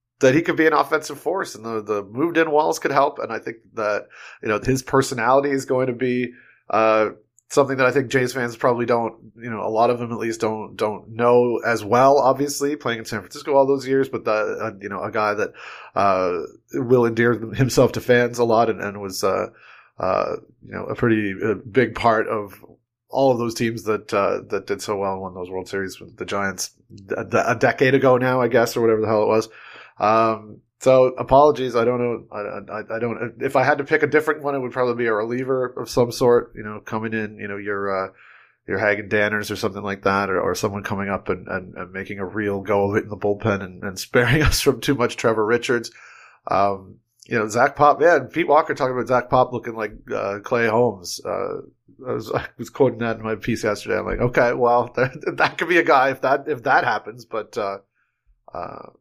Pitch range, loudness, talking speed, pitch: 105-130 Hz, -21 LUFS, 235 wpm, 120 Hz